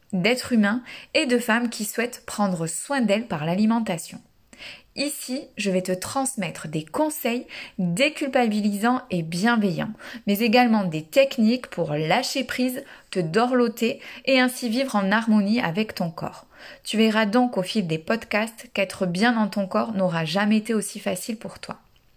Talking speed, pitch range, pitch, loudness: 155 wpm, 190-250 Hz, 220 Hz, -23 LUFS